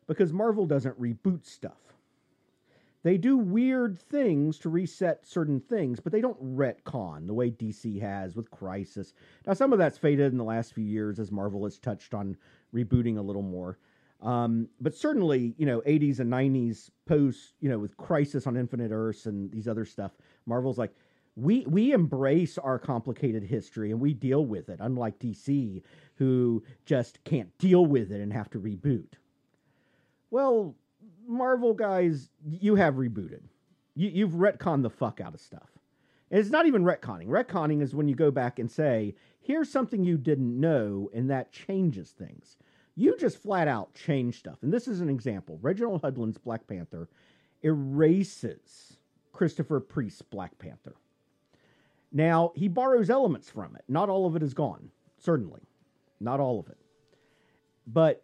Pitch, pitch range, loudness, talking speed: 140 Hz, 115-175 Hz, -28 LUFS, 165 wpm